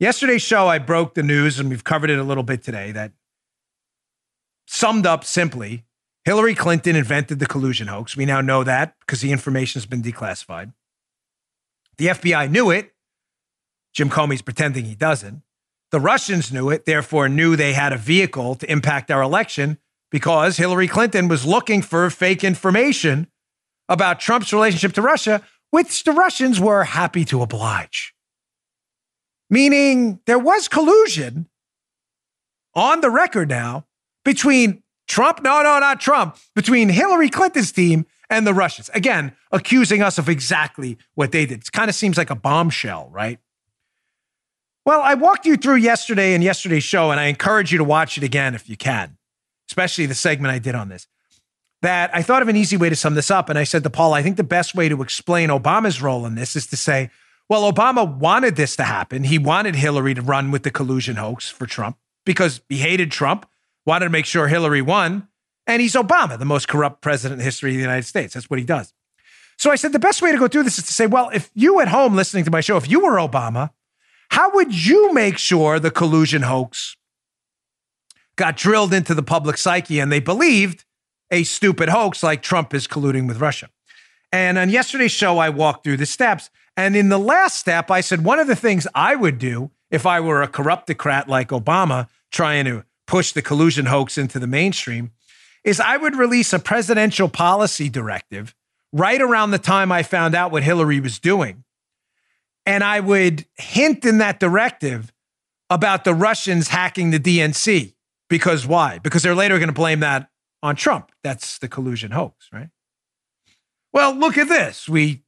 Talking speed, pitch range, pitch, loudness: 185 wpm, 140-205 Hz, 165 Hz, -17 LUFS